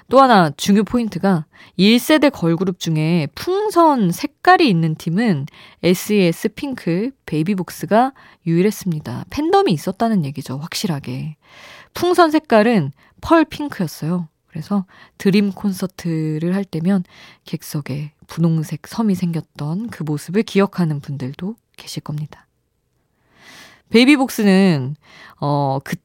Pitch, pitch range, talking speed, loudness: 185 Hz, 160-220 Hz, 265 characters per minute, -18 LUFS